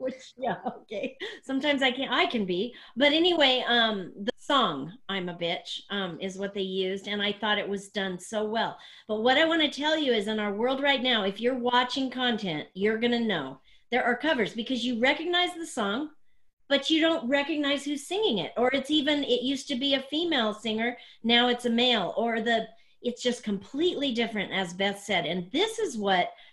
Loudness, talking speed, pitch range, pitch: -27 LUFS, 210 wpm, 205-280 Hz, 245 Hz